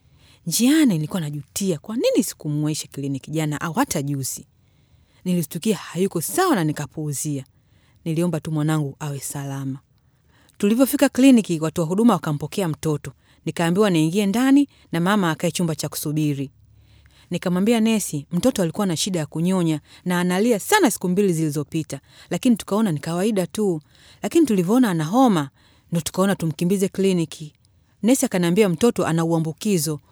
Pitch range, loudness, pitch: 150-205 Hz, -21 LUFS, 170 Hz